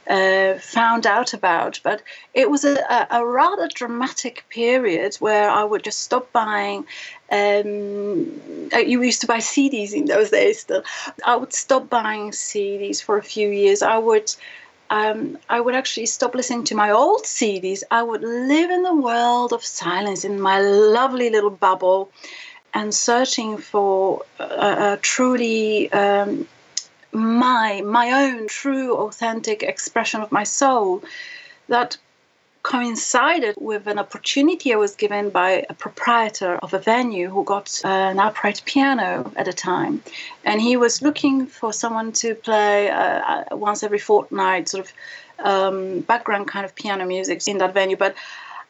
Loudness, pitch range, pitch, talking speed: -20 LUFS, 205-260 Hz, 225 Hz, 155 wpm